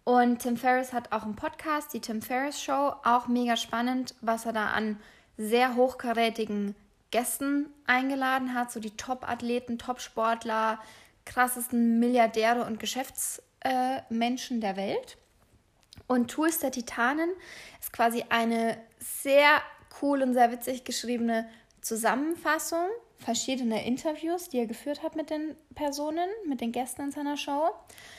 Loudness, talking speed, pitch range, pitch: -29 LUFS, 135 wpm, 230-285 Hz, 250 Hz